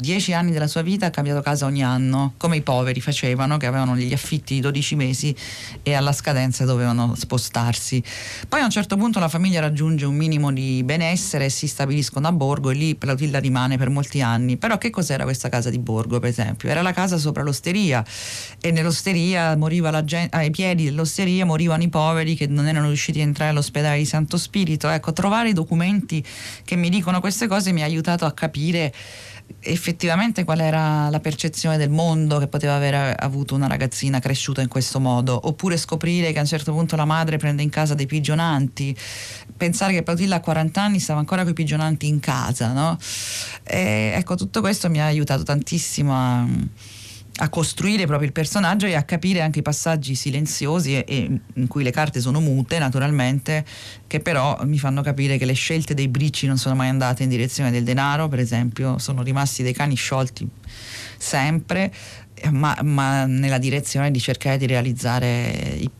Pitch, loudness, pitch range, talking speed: 145 Hz, -21 LUFS, 130-160 Hz, 190 wpm